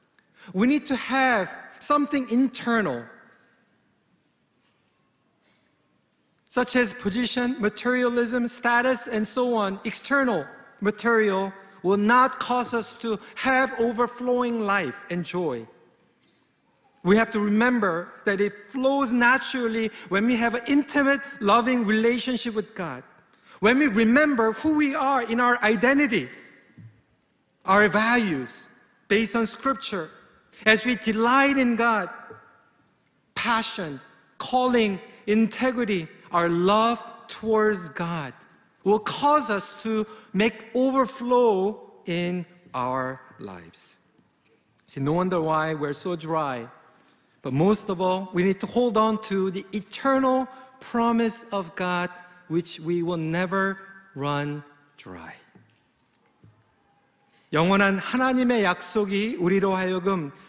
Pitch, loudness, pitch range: 220 Hz, -24 LUFS, 185-245 Hz